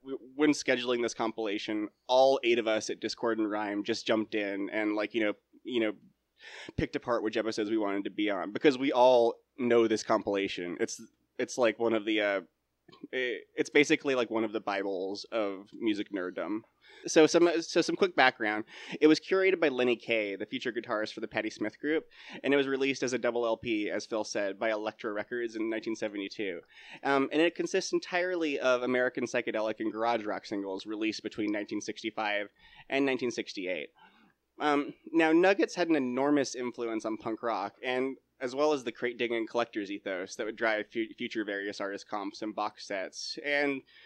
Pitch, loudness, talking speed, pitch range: 120 Hz, -30 LUFS, 185 wpm, 110-145 Hz